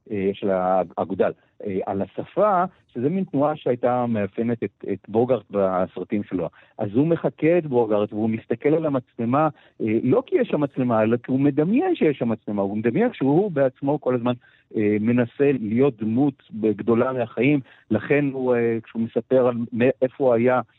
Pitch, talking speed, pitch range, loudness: 120 Hz, 160 wpm, 110-140 Hz, -22 LUFS